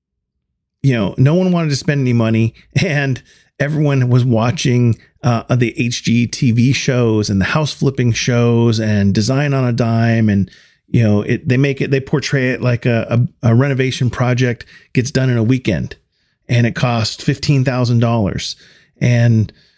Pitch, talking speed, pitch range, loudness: 120 Hz, 160 wpm, 115-135 Hz, -15 LUFS